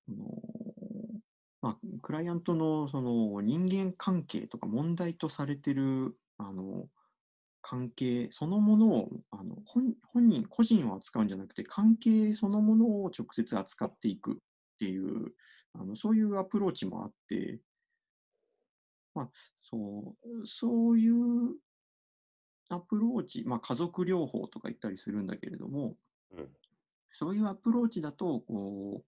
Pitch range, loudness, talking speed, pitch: 135-225 Hz, -32 LUFS, 270 characters per minute, 200 Hz